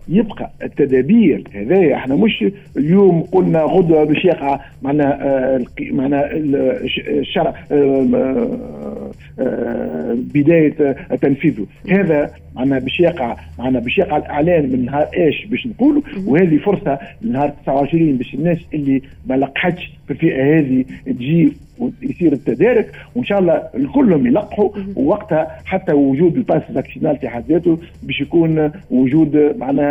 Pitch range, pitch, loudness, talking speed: 140-190 Hz, 155 Hz, -16 LUFS, 115 wpm